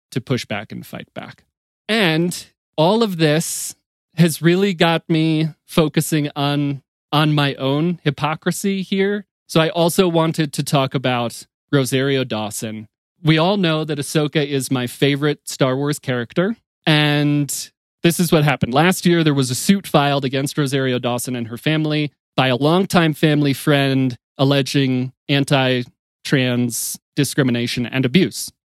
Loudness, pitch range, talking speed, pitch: -18 LUFS, 135-165 Hz, 145 wpm, 150 Hz